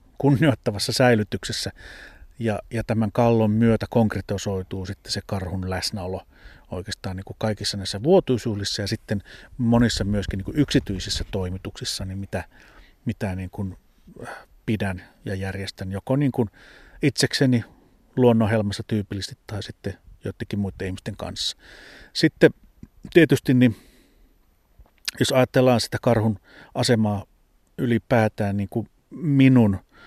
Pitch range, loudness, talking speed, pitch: 95-120 Hz, -23 LUFS, 115 wpm, 105 Hz